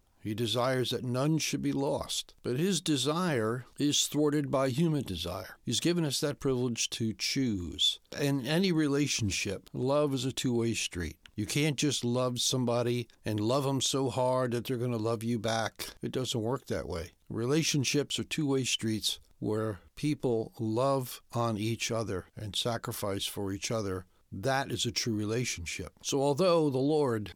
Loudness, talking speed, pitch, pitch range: -31 LUFS, 170 wpm, 120 Hz, 110-140 Hz